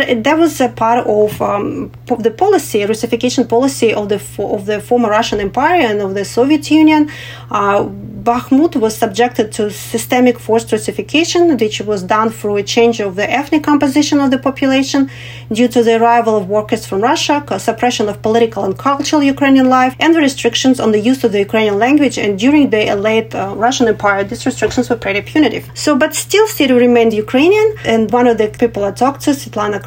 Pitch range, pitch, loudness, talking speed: 215-275 Hz, 235 Hz, -13 LUFS, 195 wpm